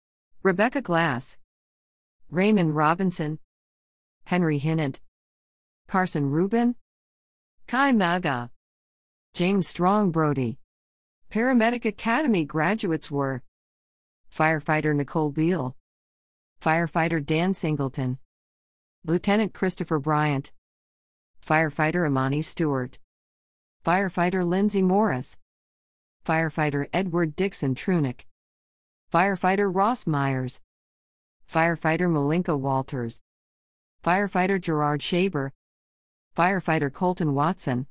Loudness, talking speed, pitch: -25 LUFS, 75 wpm, 150 Hz